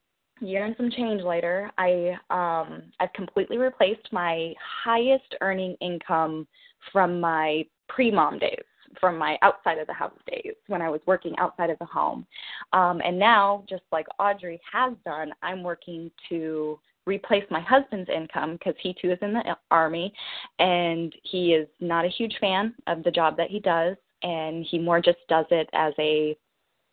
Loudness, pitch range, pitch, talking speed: -25 LUFS, 165-205 Hz, 180 Hz, 170 wpm